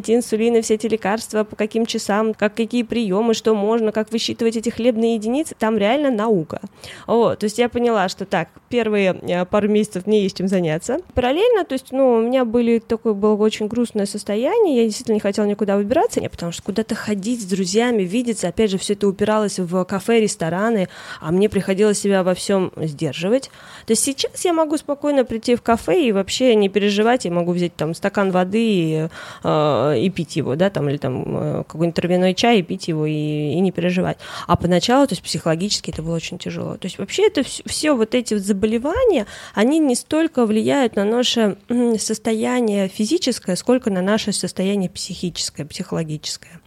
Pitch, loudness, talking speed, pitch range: 215 Hz, -19 LUFS, 185 wpm, 185-235 Hz